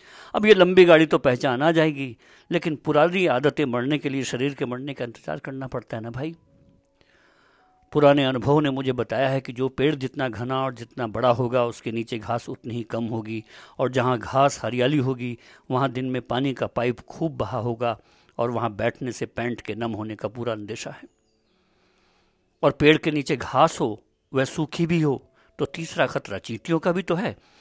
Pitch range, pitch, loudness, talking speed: 120-145 Hz, 130 Hz, -23 LUFS, 195 wpm